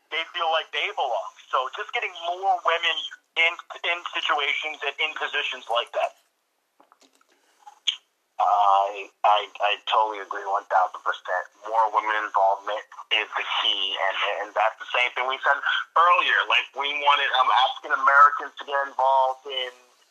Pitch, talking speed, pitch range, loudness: 135 Hz, 150 wpm, 105-165 Hz, -23 LUFS